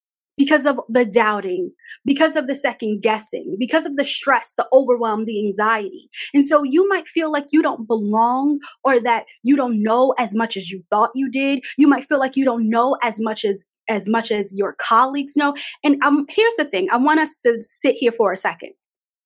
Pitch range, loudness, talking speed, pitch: 225-290 Hz, -18 LUFS, 210 wpm, 260 Hz